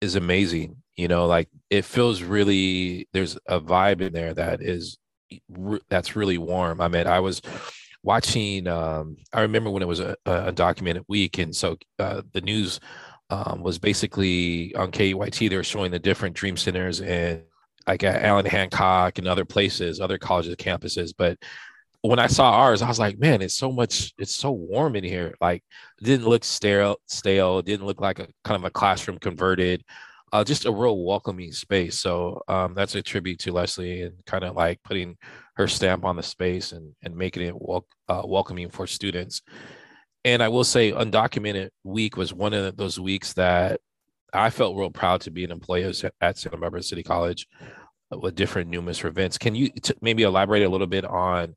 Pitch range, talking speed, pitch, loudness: 90-100 Hz, 190 wpm, 95 Hz, -24 LUFS